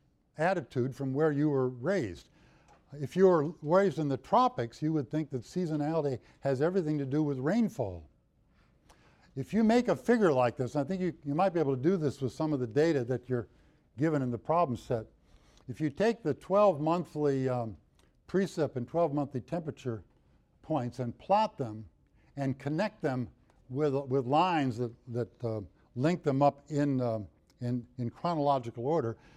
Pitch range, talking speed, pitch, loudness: 125-160 Hz, 180 wpm, 140 Hz, -31 LUFS